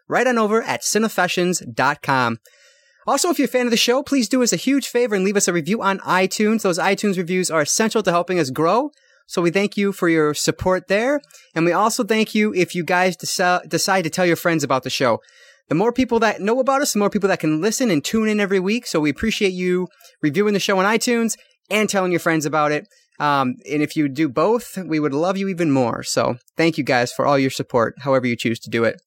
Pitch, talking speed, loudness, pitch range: 185 Hz, 245 wpm, -19 LUFS, 160-220 Hz